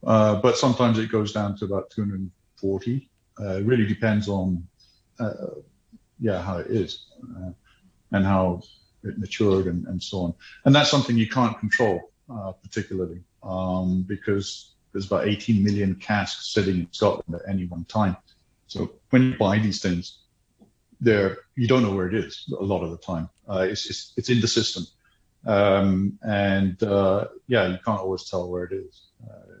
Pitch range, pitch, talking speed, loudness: 95-110 Hz, 100 Hz, 175 wpm, -24 LUFS